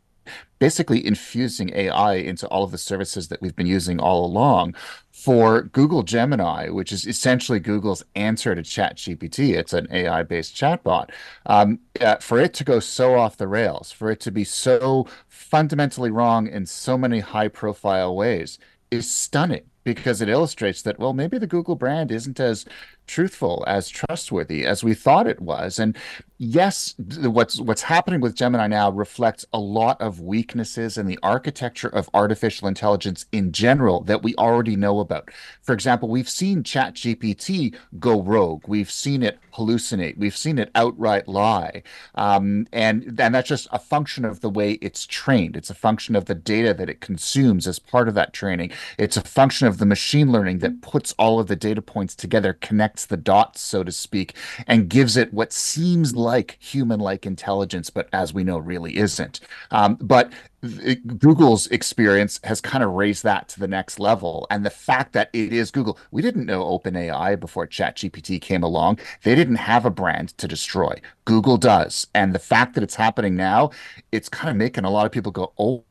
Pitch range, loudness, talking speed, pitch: 100-125 Hz, -21 LUFS, 185 wpm, 110 Hz